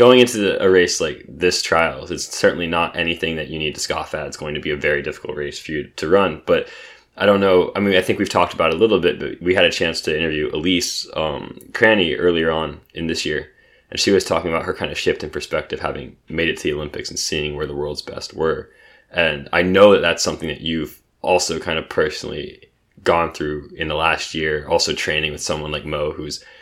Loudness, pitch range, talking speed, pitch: -19 LUFS, 75-95 Hz, 245 wpm, 80 Hz